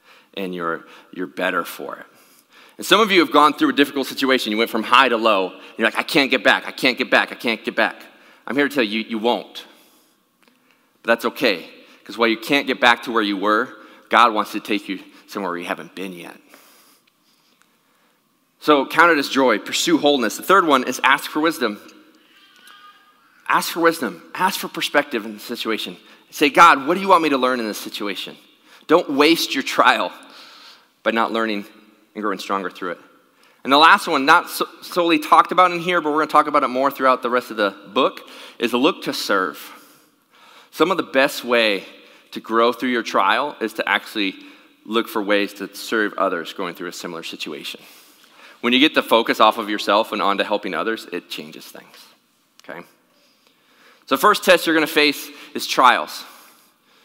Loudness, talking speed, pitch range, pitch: -18 LUFS, 205 wpm, 110-150 Hz, 120 Hz